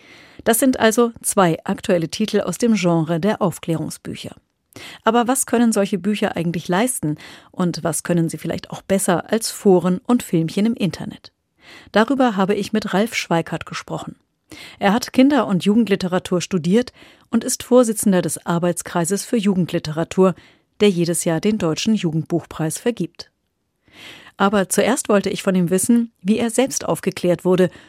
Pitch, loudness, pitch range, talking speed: 195 Hz, -19 LUFS, 175-225 Hz, 150 wpm